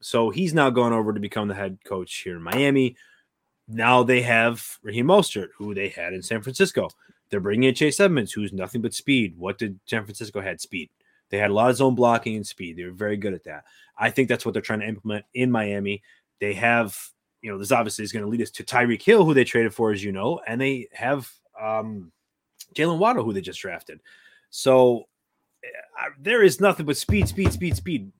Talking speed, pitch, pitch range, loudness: 225 wpm, 115 Hz, 105-130 Hz, -23 LUFS